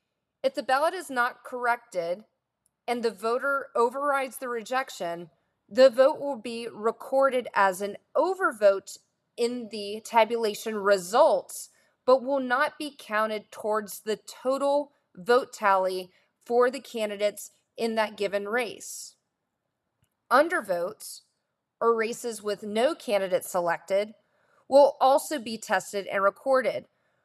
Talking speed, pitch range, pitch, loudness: 120 wpm, 205-265 Hz, 235 Hz, -26 LUFS